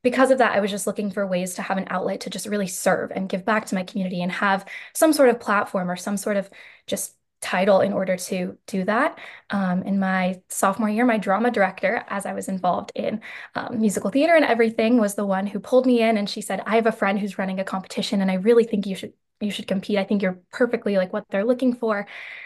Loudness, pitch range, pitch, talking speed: -22 LUFS, 190-225 Hz, 205 Hz, 250 wpm